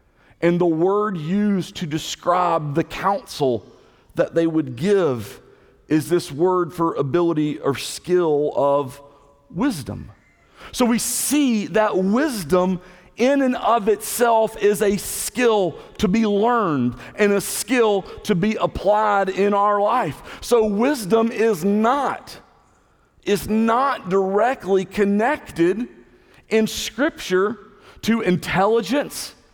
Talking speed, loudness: 115 wpm, -20 LUFS